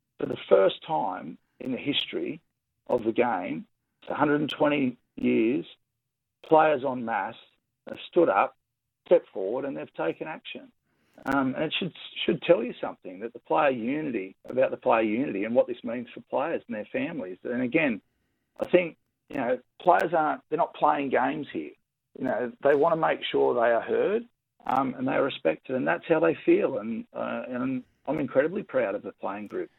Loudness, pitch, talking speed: -27 LUFS, 235 Hz, 185 wpm